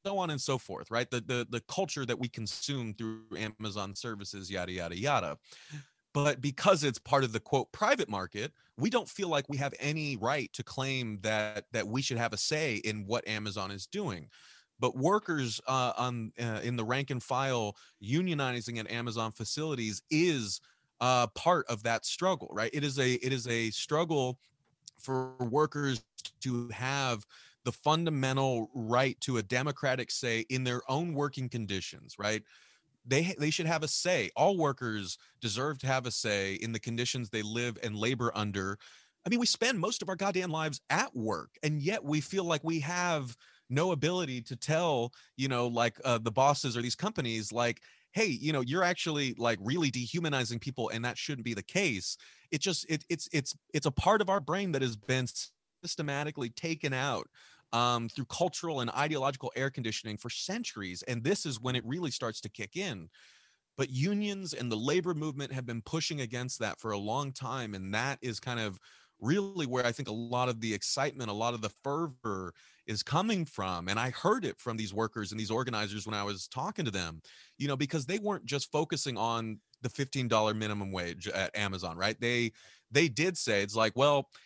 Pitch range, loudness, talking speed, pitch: 115-150 Hz, -33 LUFS, 195 wpm, 125 Hz